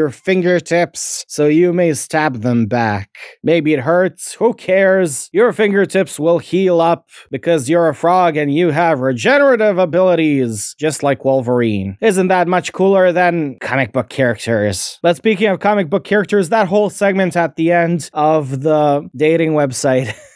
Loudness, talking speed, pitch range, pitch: -14 LUFS, 160 wpm, 140-185 Hz, 165 Hz